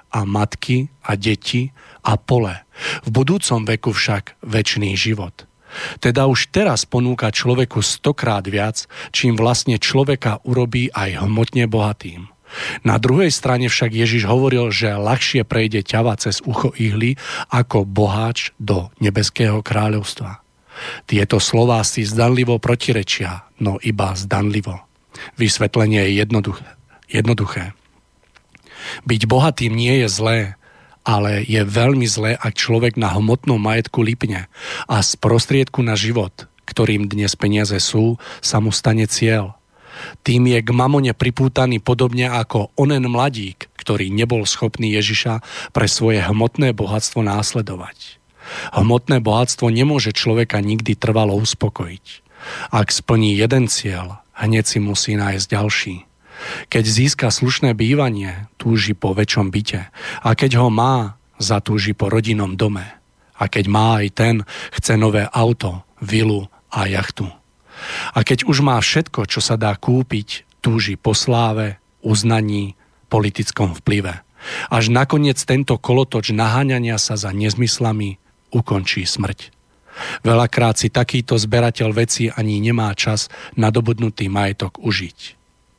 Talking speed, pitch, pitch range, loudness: 125 wpm, 110 Hz, 105-120 Hz, -17 LUFS